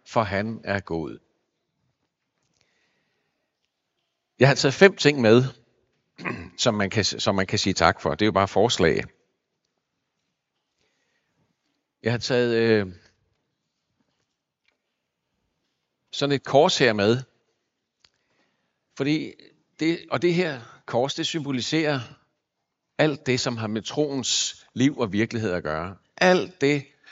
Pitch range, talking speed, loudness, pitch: 110-145 Hz, 120 wpm, -23 LUFS, 120 Hz